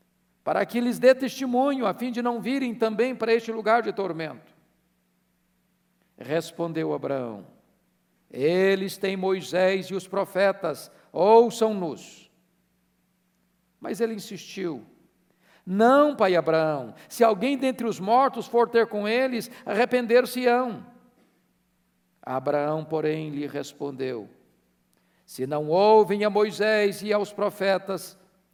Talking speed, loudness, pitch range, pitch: 110 wpm, -24 LUFS, 155-230 Hz, 195 Hz